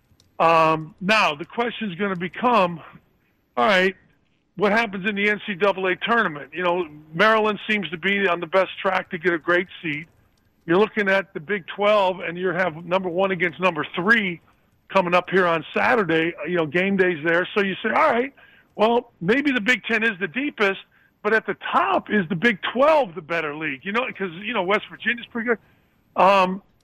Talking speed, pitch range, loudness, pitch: 200 wpm, 175-215 Hz, -21 LUFS, 190 Hz